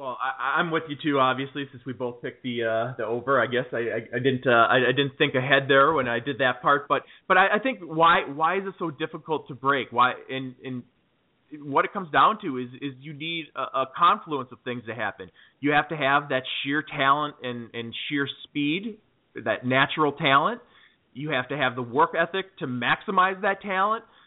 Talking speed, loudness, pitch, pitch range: 225 wpm, -24 LUFS, 140 Hz, 125-160 Hz